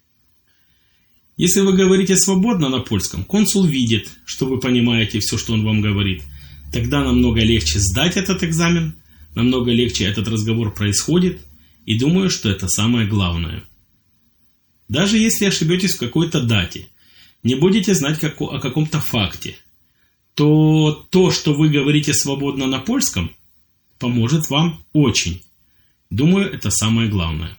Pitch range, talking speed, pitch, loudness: 100-160 Hz, 135 wpm, 120 Hz, -17 LUFS